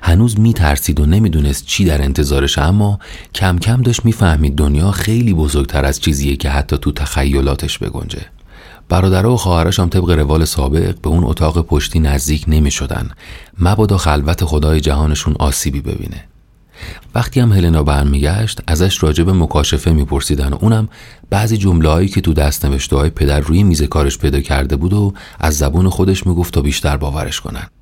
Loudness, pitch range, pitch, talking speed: -14 LUFS, 75-95 Hz, 80 Hz, 165 wpm